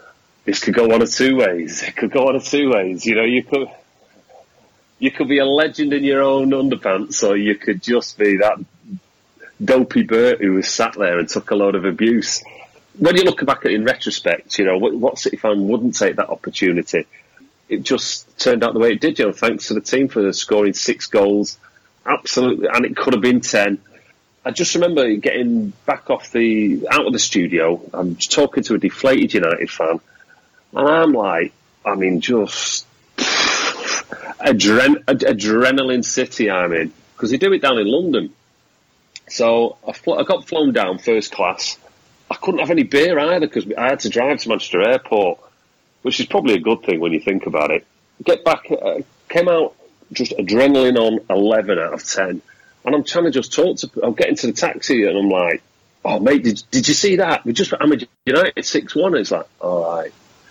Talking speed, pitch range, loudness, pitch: 200 wpm, 105-145 Hz, -17 LUFS, 125 Hz